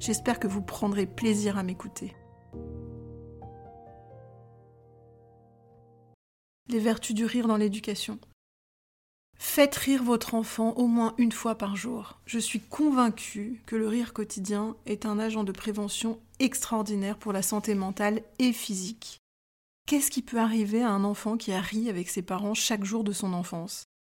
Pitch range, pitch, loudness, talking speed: 180-225 Hz, 210 Hz, -29 LUFS, 150 wpm